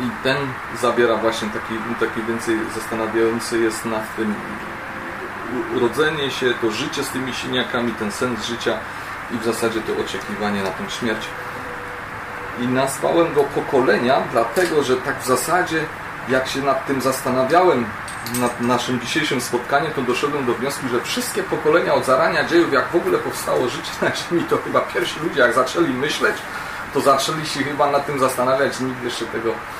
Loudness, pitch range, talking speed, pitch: -20 LUFS, 115-140 Hz, 165 wpm, 125 Hz